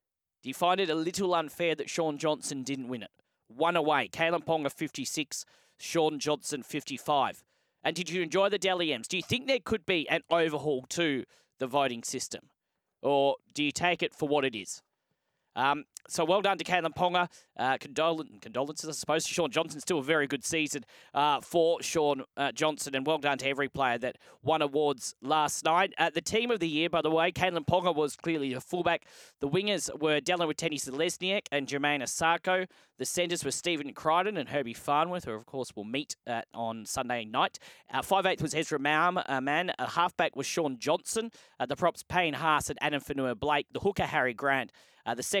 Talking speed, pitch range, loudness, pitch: 205 wpm, 140-170 Hz, -30 LUFS, 155 Hz